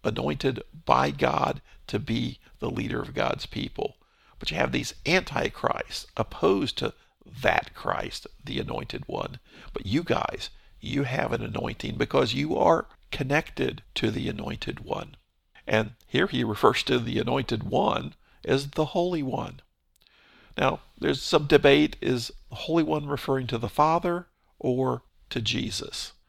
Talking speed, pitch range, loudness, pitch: 145 wpm, 120-155 Hz, -27 LUFS, 135 Hz